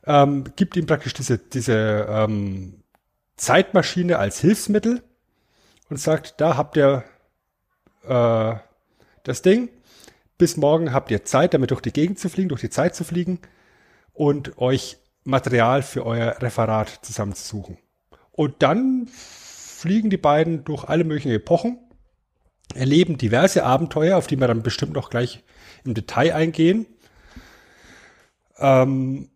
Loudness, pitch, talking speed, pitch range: -21 LUFS, 140 Hz, 130 wpm, 120-170 Hz